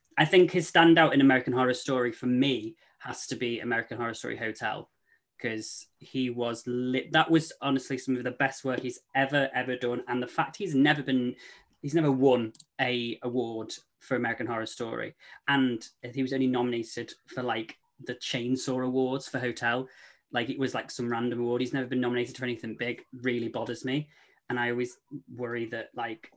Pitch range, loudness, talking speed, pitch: 120-135 Hz, -29 LUFS, 190 wpm, 125 Hz